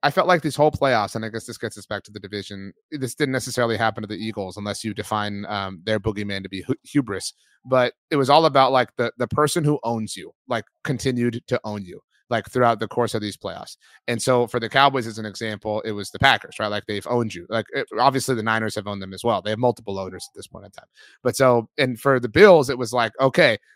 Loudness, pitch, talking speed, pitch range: -22 LUFS, 115 Hz, 260 wpm, 105-130 Hz